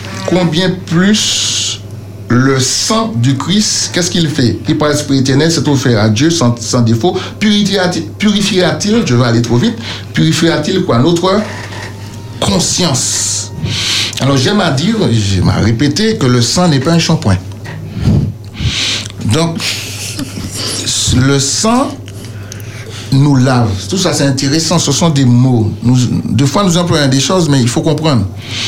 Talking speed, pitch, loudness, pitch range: 140 wpm, 130 Hz, -11 LUFS, 110-165 Hz